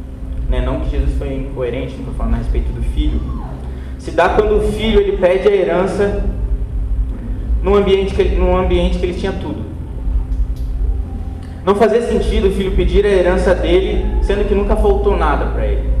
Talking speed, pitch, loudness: 175 wpm, 170 Hz, -17 LUFS